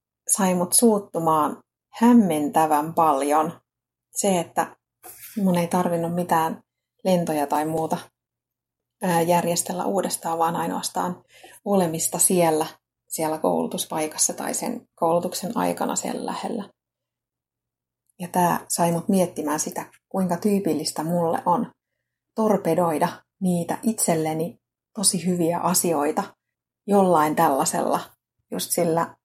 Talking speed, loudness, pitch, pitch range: 100 wpm, -23 LUFS, 170 Hz, 155-185 Hz